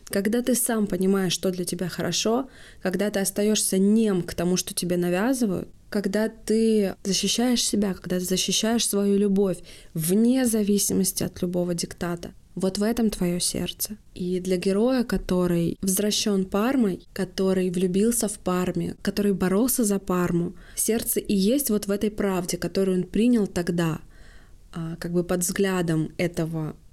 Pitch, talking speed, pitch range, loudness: 195 Hz, 145 wpm, 180-215 Hz, -24 LUFS